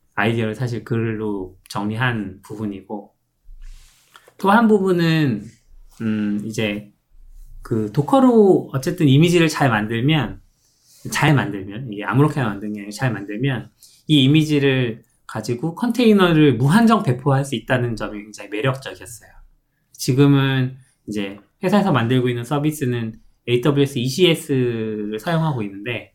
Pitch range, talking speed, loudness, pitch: 105-145 Hz, 290 characters per minute, -19 LUFS, 125 Hz